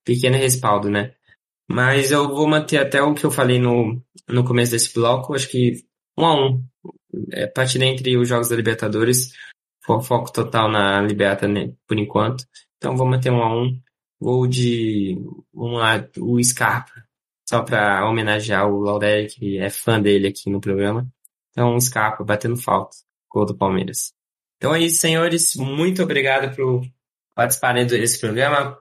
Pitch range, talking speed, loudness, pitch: 105-130 Hz, 160 wpm, -19 LUFS, 120 Hz